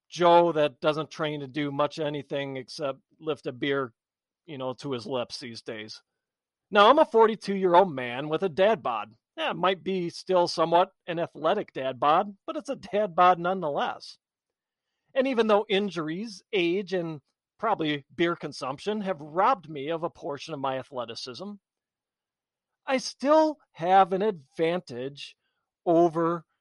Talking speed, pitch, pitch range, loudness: 160 wpm, 170 Hz, 145-195 Hz, -26 LUFS